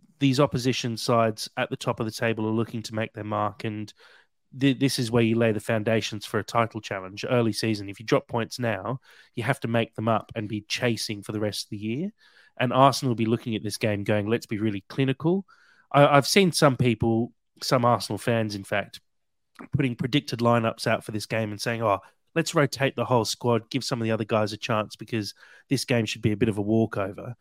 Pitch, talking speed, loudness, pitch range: 115 Hz, 230 wpm, -26 LUFS, 110-130 Hz